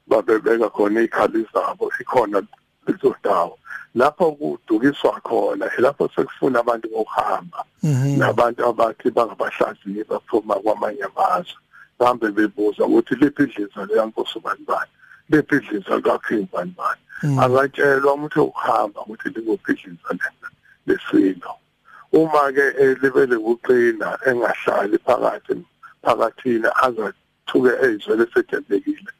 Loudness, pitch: -20 LUFS, 320 Hz